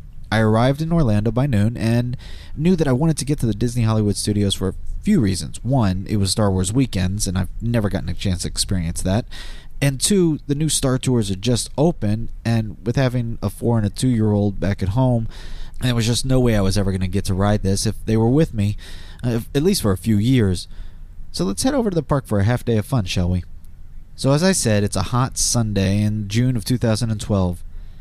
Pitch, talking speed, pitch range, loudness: 105 Hz, 240 wpm, 95-125 Hz, -20 LUFS